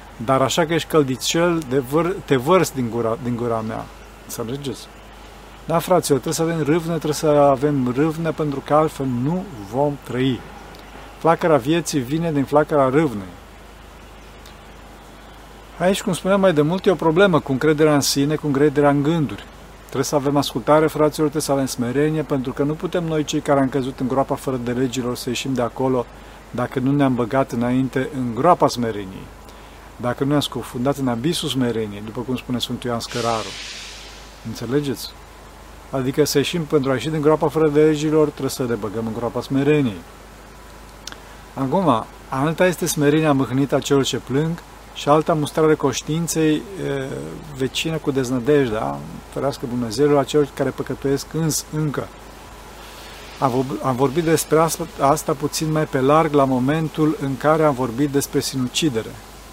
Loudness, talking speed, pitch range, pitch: -20 LUFS, 165 wpm, 125-155 Hz, 140 Hz